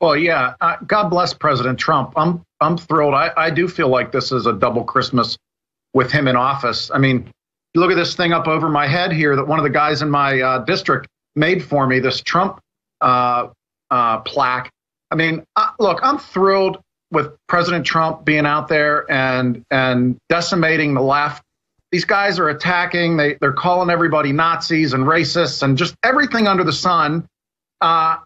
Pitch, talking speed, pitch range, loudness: 155 Hz, 185 wpm, 135-175 Hz, -17 LUFS